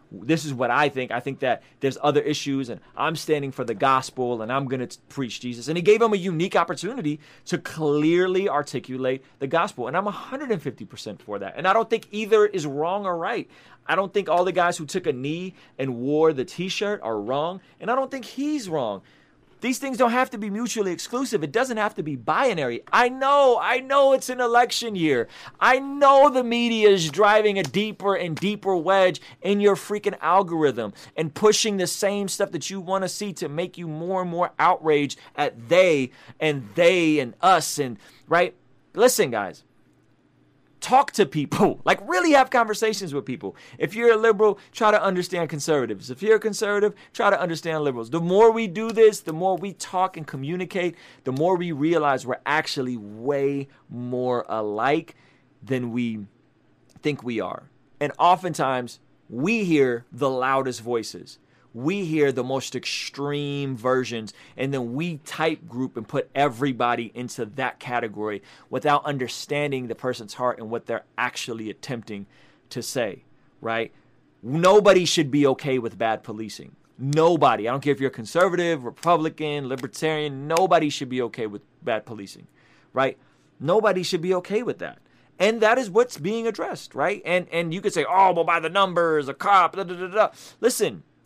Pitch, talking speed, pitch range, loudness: 160 Hz, 180 wpm, 130-195 Hz, -23 LUFS